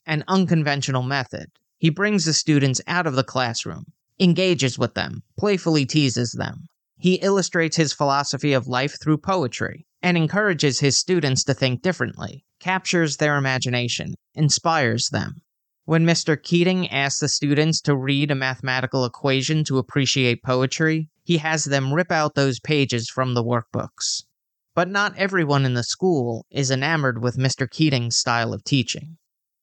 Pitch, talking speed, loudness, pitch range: 145 Hz, 150 wpm, -21 LUFS, 130-165 Hz